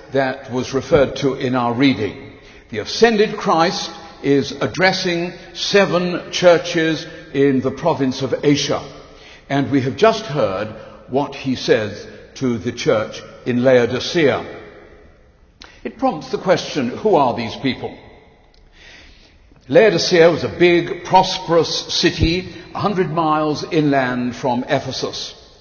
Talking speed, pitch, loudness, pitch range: 120 wpm, 145 Hz, -18 LUFS, 130-175 Hz